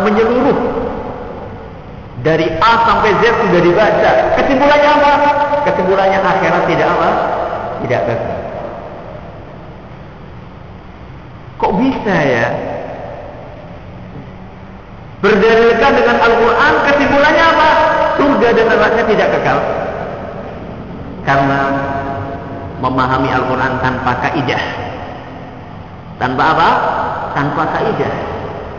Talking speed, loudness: 75 wpm, -12 LUFS